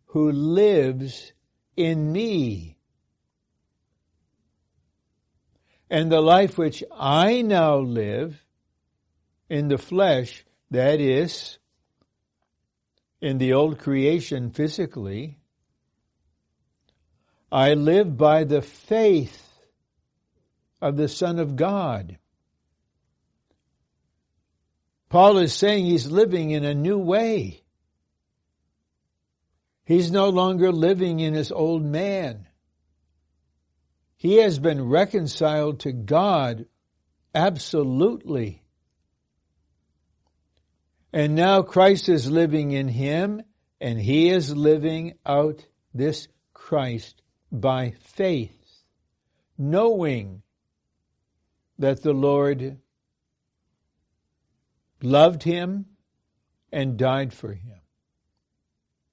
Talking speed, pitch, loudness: 80 wpm, 135 Hz, -22 LUFS